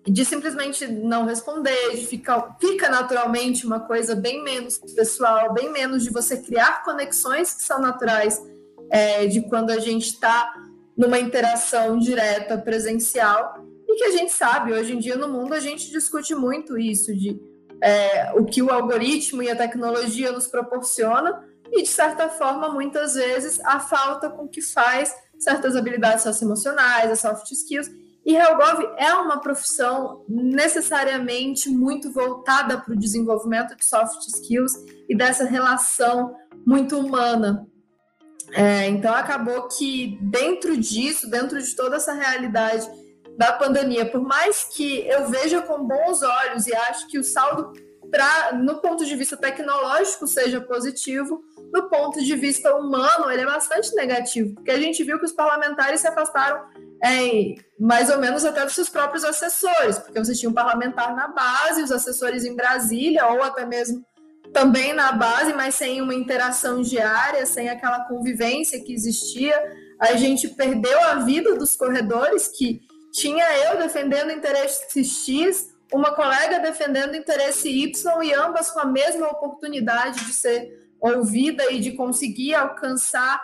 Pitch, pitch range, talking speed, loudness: 260 Hz, 240-295 Hz, 155 wpm, -21 LUFS